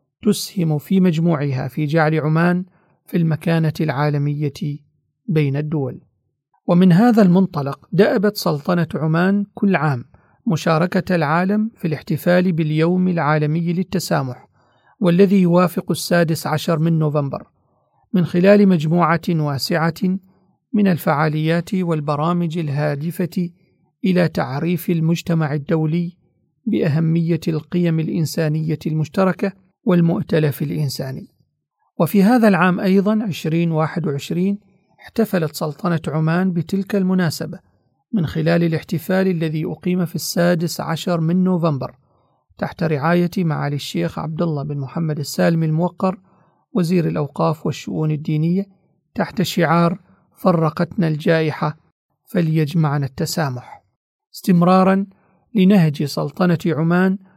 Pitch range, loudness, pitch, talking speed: 155-185 Hz, -19 LUFS, 170 Hz, 100 wpm